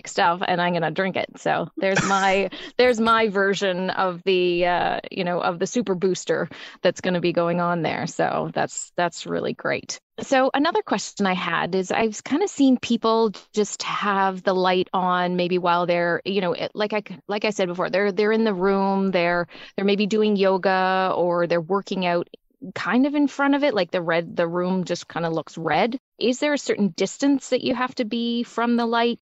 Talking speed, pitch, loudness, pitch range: 210 wpm, 195 Hz, -22 LUFS, 180-225 Hz